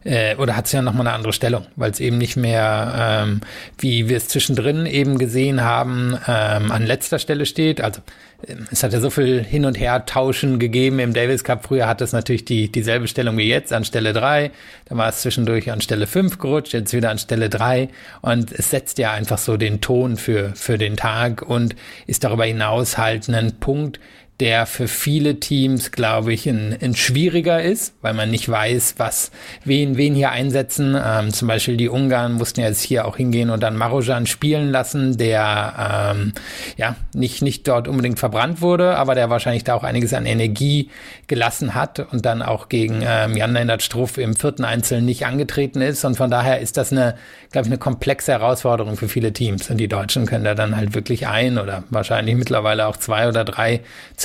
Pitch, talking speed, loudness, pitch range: 120 Hz, 200 wpm, -19 LUFS, 110-130 Hz